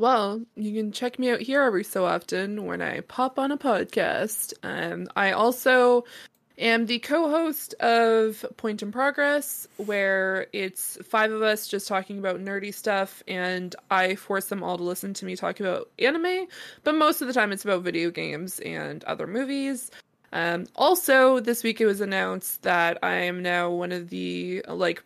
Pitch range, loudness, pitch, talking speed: 190-255 Hz, -25 LUFS, 215 Hz, 180 wpm